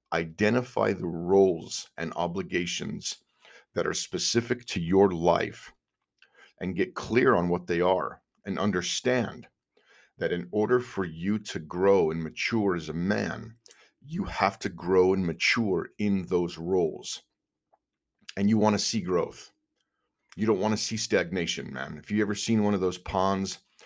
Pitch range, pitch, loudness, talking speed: 90-105 Hz, 95 Hz, -27 LUFS, 155 wpm